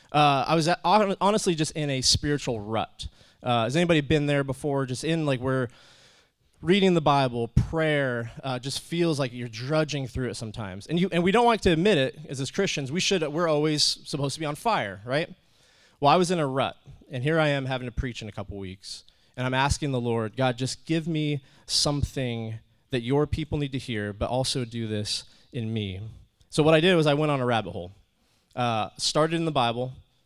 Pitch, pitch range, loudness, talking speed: 135 Hz, 120-155 Hz, -25 LUFS, 220 wpm